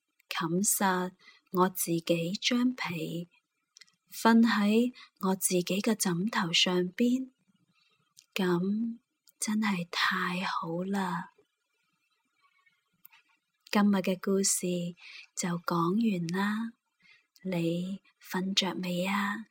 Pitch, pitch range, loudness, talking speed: 190 Hz, 180-215 Hz, -29 LUFS, 115 characters per minute